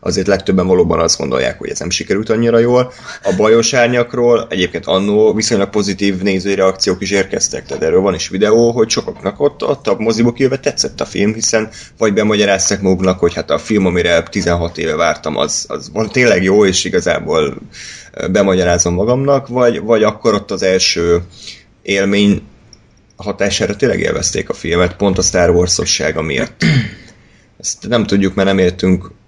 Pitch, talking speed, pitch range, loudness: 100 Hz, 165 wpm, 95-115 Hz, -14 LUFS